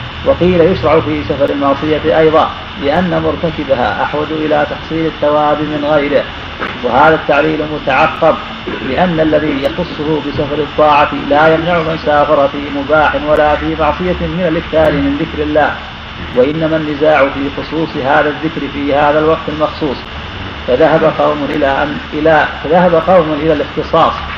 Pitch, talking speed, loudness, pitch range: 150 Hz, 135 wpm, -12 LUFS, 145-160 Hz